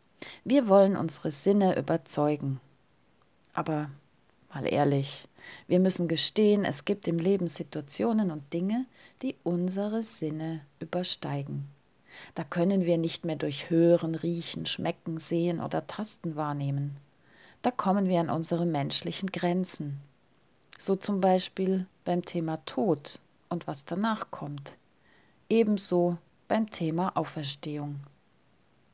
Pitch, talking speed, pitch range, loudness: 170 Hz, 115 wpm, 150-190 Hz, -29 LUFS